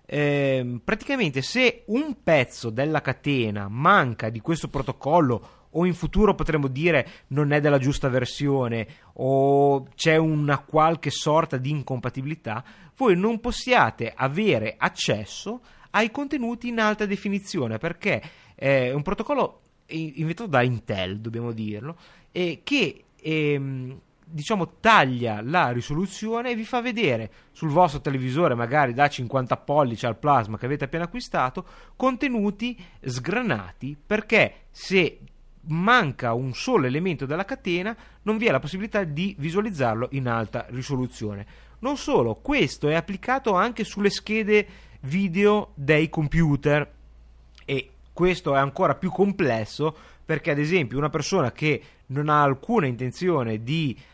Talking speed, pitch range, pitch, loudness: 135 wpm, 130-195 Hz, 150 Hz, -24 LUFS